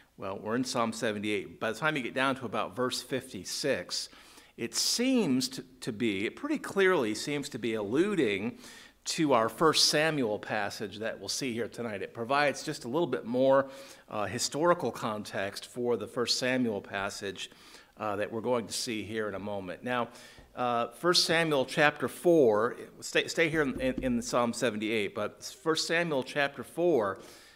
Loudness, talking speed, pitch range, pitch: -30 LUFS, 175 wpm, 115-155 Hz, 125 Hz